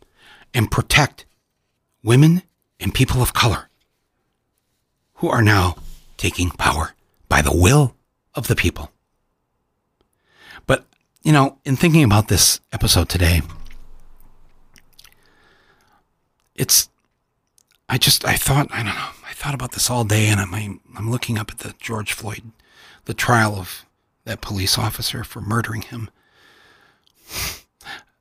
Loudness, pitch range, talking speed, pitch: -18 LUFS, 100-130 Hz, 125 wpm, 115 Hz